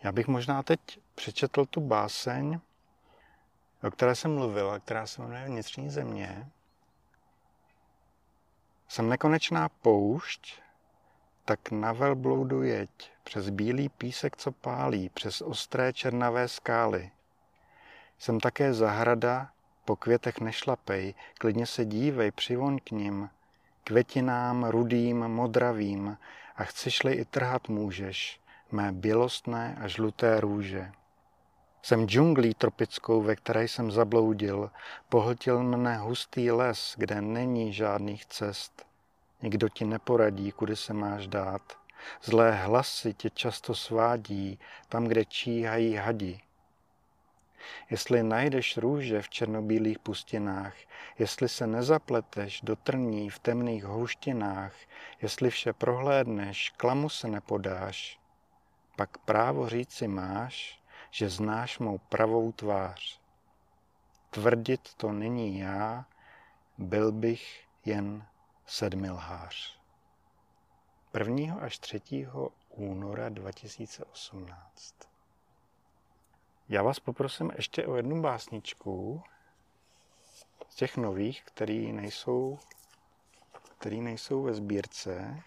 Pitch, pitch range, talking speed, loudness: 115 Hz, 105-125 Hz, 105 wpm, -30 LUFS